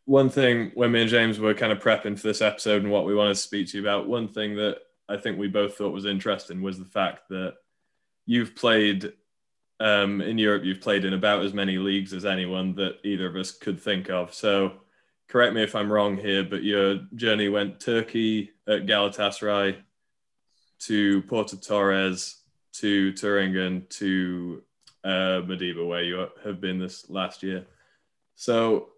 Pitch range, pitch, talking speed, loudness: 95-105 Hz, 100 Hz, 180 wpm, -25 LUFS